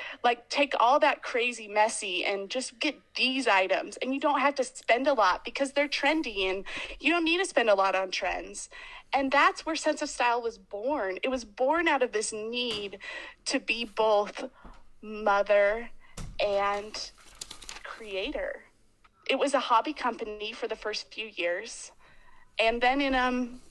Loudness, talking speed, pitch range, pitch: -28 LUFS, 170 wpm, 210-280 Hz, 240 Hz